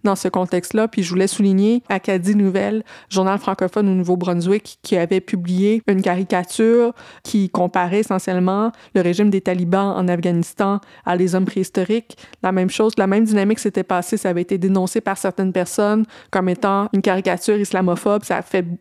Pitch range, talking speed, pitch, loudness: 185-210 Hz, 170 wpm, 195 Hz, -19 LUFS